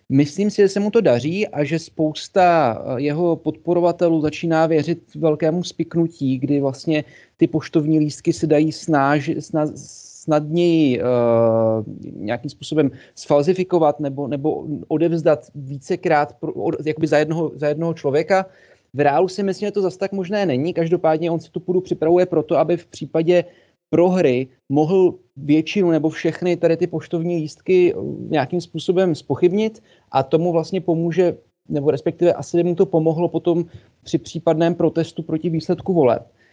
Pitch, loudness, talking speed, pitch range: 165 Hz, -19 LUFS, 150 wpm, 150-175 Hz